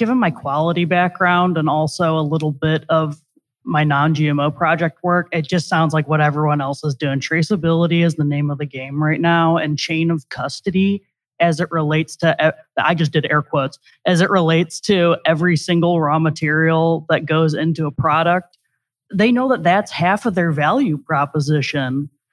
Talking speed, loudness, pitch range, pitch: 185 wpm, -17 LUFS, 150-170 Hz, 160 Hz